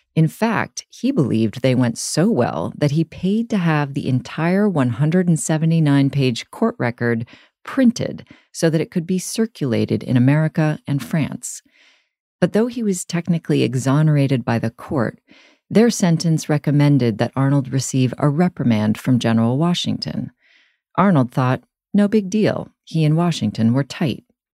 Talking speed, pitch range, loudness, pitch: 145 wpm, 130-180 Hz, -19 LUFS, 150 Hz